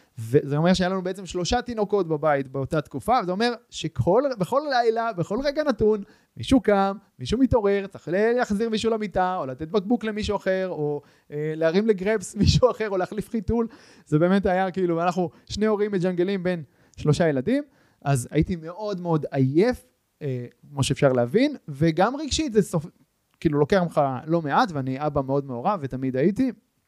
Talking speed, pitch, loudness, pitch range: 165 wpm, 180 Hz, -24 LUFS, 150-215 Hz